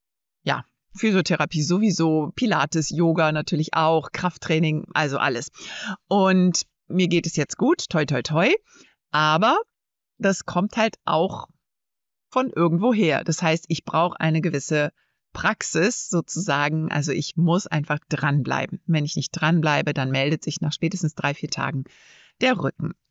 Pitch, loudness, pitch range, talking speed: 165 Hz, -23 LUFS, 150-185 Hz, 140 wpm